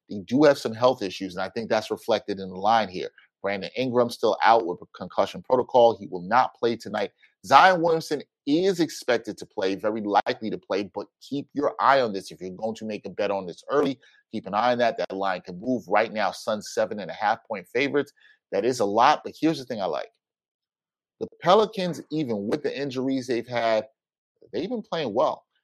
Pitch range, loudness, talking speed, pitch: 100-160 Hz, -25 LUFS, 220 wpm, 125 Hz